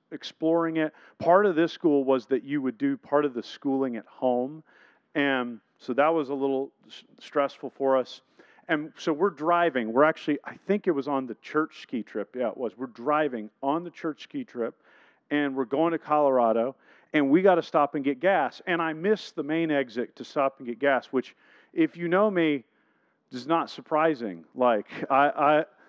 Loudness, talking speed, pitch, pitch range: -26 LUFS, 200 wpm, 145 Hz, 135-165 Hz